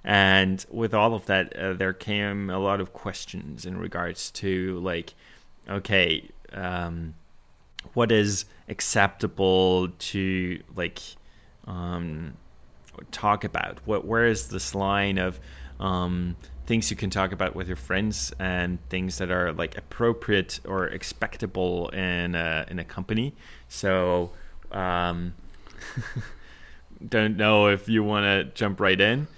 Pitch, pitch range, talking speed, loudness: 95 Hz, 90-100 Hz, 135 wpm, -26 LUFS